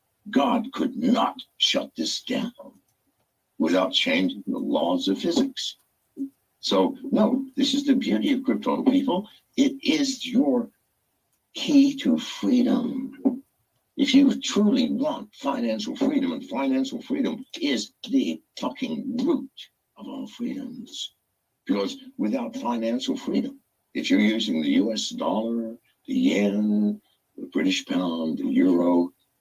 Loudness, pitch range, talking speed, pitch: -24 LUFS, 245-275 Hz, 120 wpm, 265 Hz